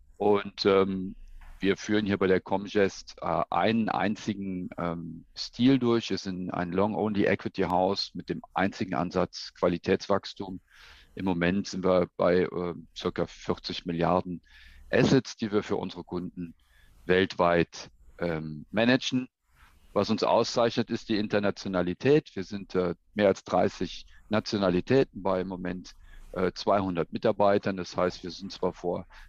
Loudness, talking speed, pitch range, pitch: -28 LUFS, 135 wpm, 90-105 Hz, 95 Hz